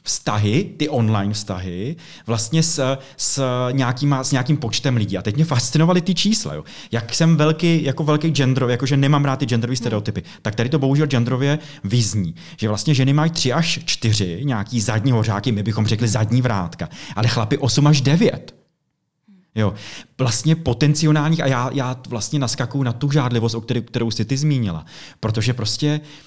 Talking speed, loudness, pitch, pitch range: 170 wpm, -19 LUFS, 130 Hz, 115-150 Hz